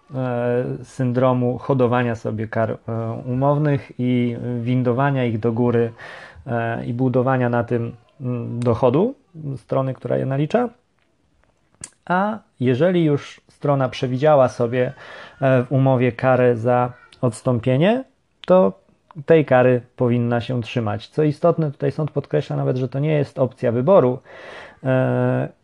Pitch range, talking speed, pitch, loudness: 120-145 Hz, 125 wpm, 125 Hz, -20 LUFS